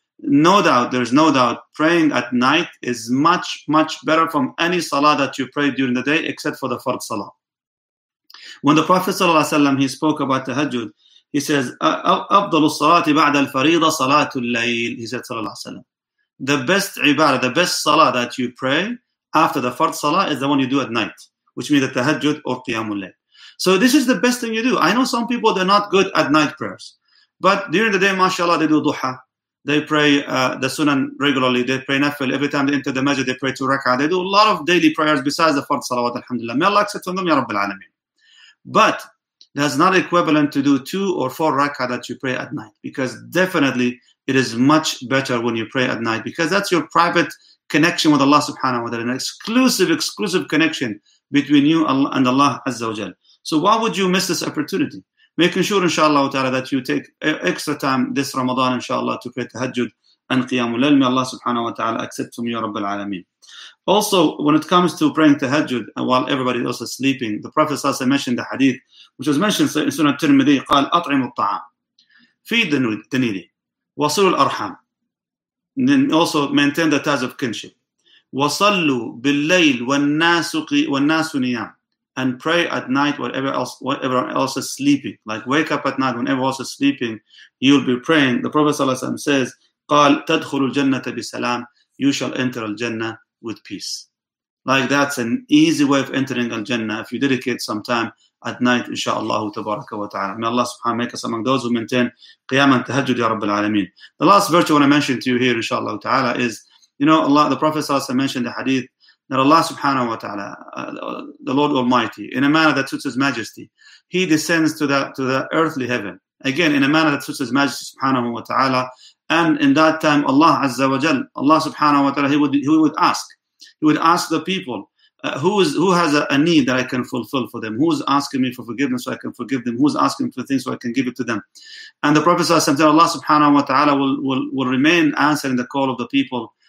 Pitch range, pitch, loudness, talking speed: 130-165 Hz, 140 Hz, -18 LUFS, 200 wpm